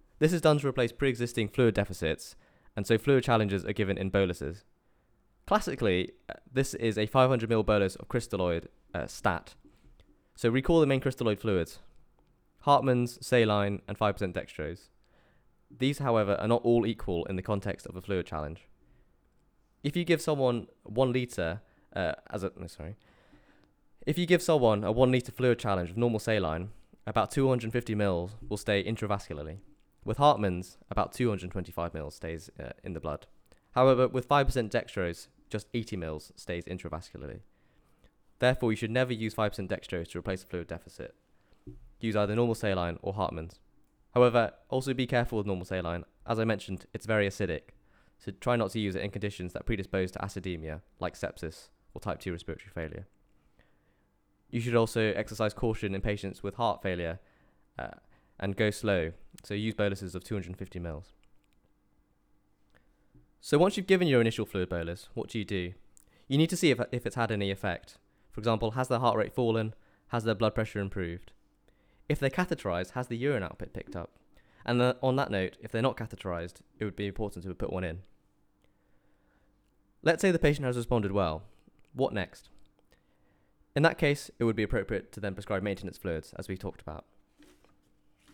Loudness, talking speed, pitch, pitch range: -30 LUFS, 175 wpm, 105 Hz, 95-120 Hz